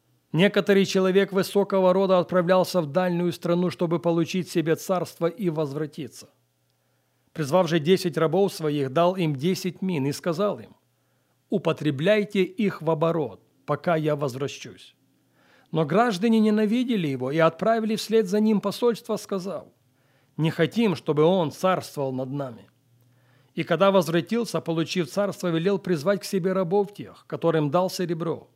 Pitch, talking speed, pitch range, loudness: 175 Hz, 135 wpm, 155-195 Hz, -24 LUFS